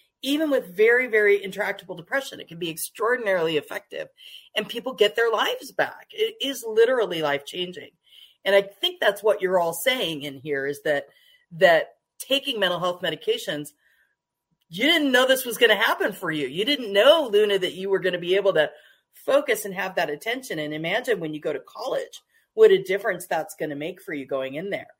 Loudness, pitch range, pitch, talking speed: -23 LUFS, 170-275 Hz, 205 Hz, 205 wpm